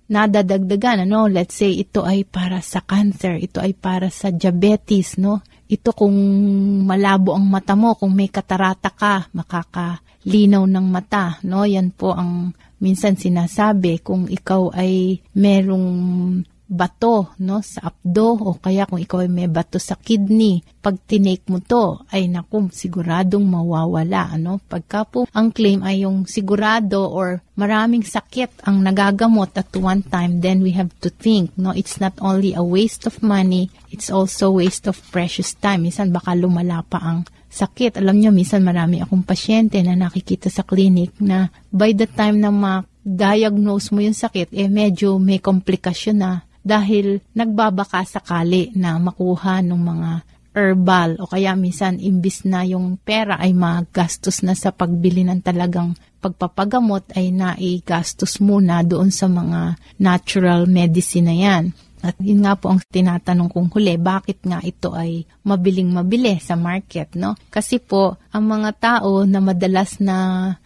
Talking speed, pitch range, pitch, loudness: 155 wpm, 180-200 Hz, 190 Hz, -18 LUFS